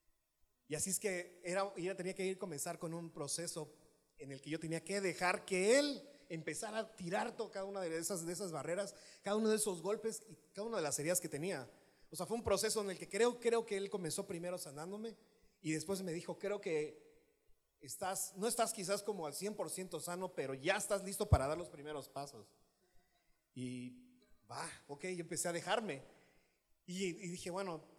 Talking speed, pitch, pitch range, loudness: 205 wpm, 185 Hz, 165-205 Hz, -40 LUFS